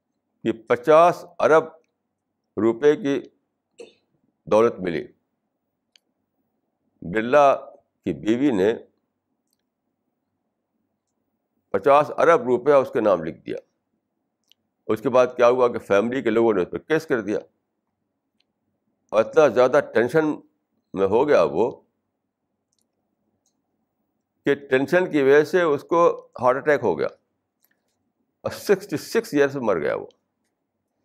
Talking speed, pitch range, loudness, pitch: 115 wpm, 125-200 Hz, -21 LUFS, 150 Hz